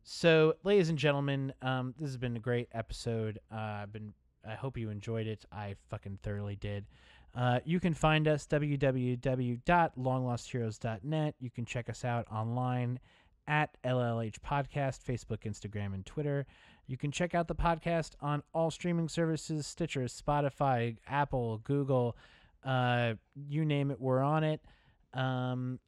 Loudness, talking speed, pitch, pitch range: -34 LUFS, 145 wpm, 130 Hz, 115-145 Hz